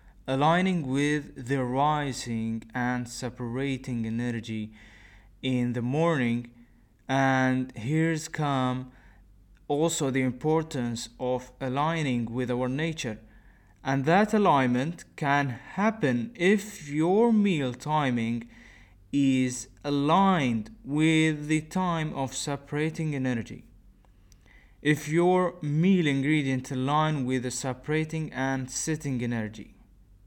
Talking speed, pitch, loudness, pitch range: 95 wpm, 130 Hz, -27 LUFS, 120-155 Hz